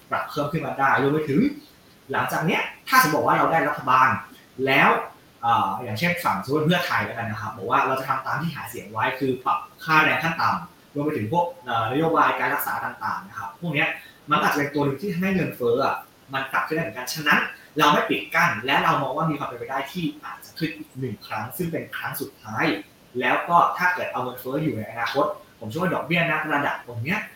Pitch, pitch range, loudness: 150 Hz, 135-170 Hz, -23 LUFS